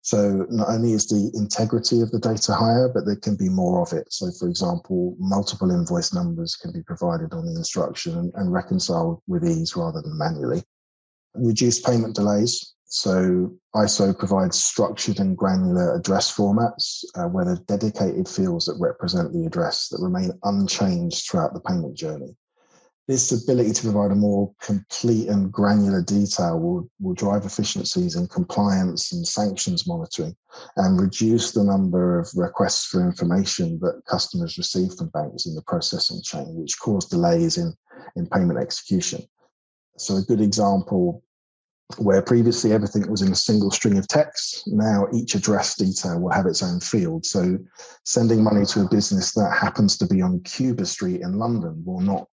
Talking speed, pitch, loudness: 170 wpm, 160 Hz, -22 LUFS